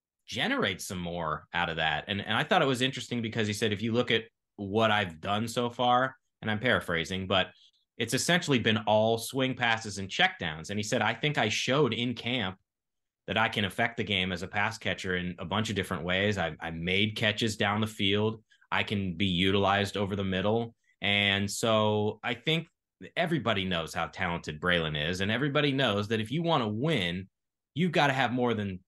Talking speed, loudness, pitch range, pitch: 210 wpm, -29 LUFS, 95-115 Hz, 105 Hz